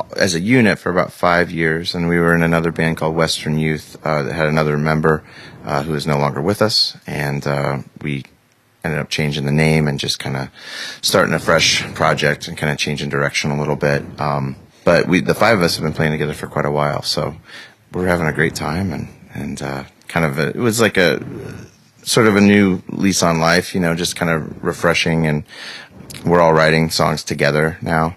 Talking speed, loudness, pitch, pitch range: 220 wpm, -17 LUFS, 80 Hz, 75-85 Hz